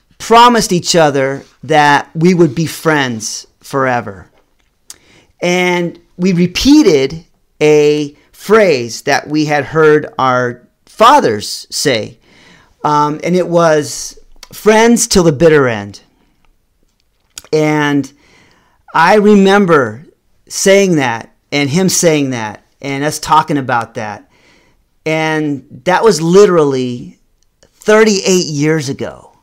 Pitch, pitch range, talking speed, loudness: 155 Hz, 140-180 Hz, 105 wpm, -11 LUFS